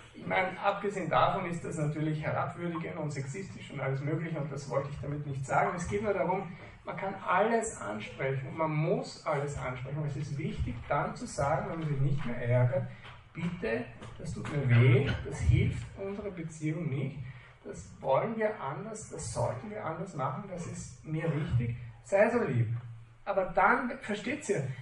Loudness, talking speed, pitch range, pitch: -32 LUFS, 180 wpm, 130-180 Hz, 150 Hz